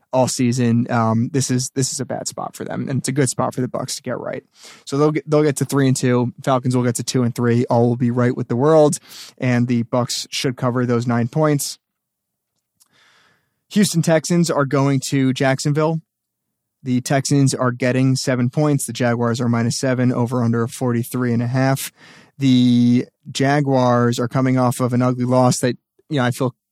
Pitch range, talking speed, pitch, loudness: 120-140 Hz, 205 wpm, 125 Hz, -18 LUFS